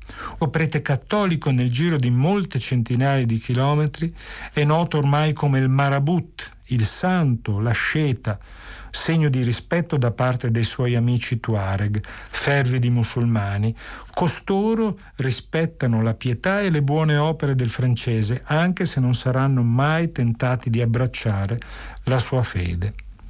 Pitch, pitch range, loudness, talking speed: 130 Hz, 115-150 Hz, -21 LUFS, 135 wpm